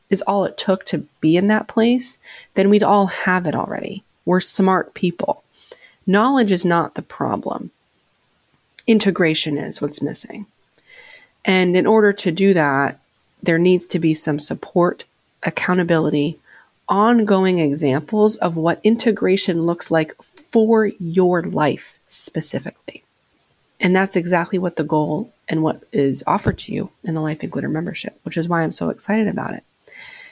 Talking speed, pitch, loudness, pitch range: 150 wpm, 185 Hz, -18 LUFS, 165-210 Hz